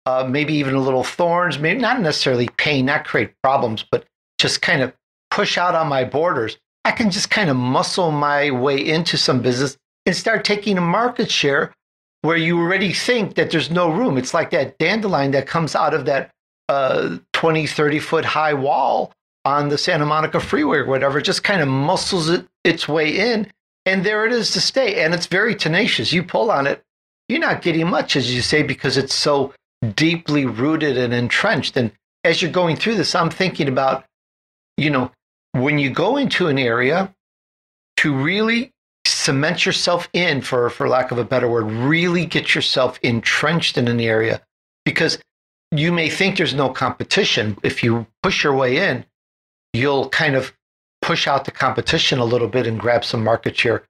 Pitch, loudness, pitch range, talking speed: 150 Hz, -18 LUFS, 130-175 Hz, 190 wpm